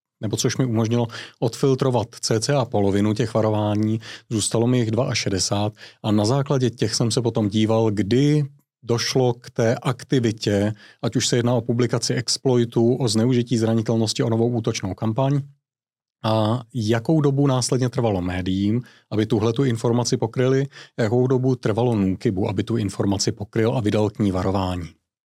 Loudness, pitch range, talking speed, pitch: -21 LUFS, 110-130 Hz, 155 wpm, 115 Hz